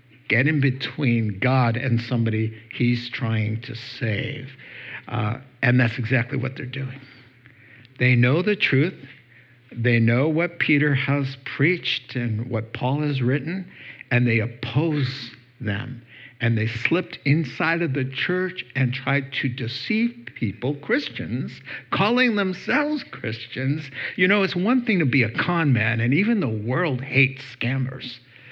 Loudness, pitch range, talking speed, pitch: -23 LUFS, 120-145 Hz, 145 wpm, 130 Hz